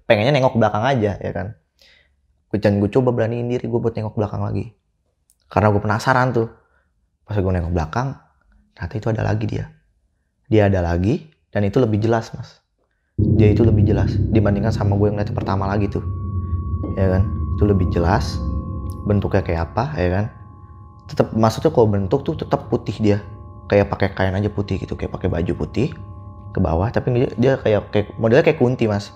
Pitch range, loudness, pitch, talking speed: 95-115 Hz, -20 LUFS, 105 Hz, 180 wpm